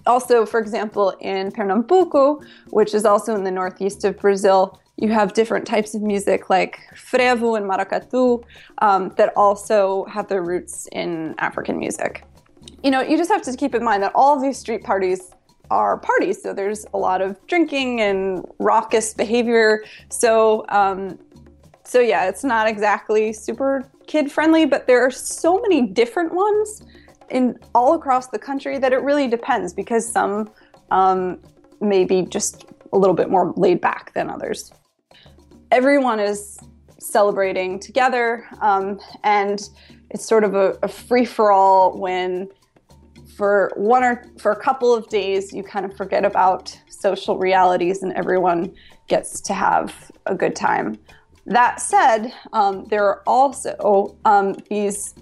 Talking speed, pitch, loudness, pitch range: 155 wpm, 210 Hz, -19 LUFS, 195-250 Hz